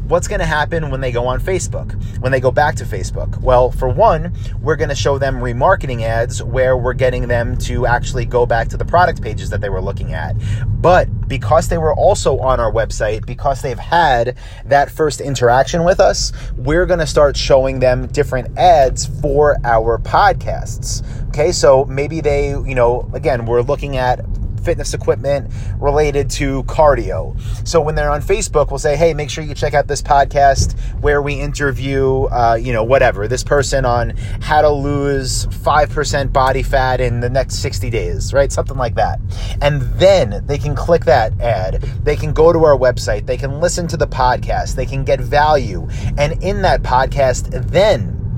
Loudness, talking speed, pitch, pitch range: -15 LUFS, 190 wpm, 125 Hz, 115-140 Hz